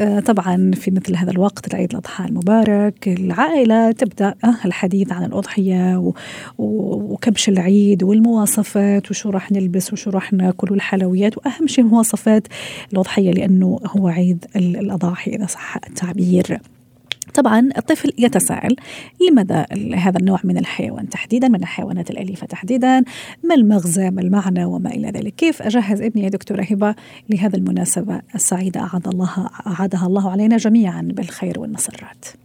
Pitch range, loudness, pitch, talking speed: 185-220 Hz, -17 LUFS, 200 Hz, 130 wpm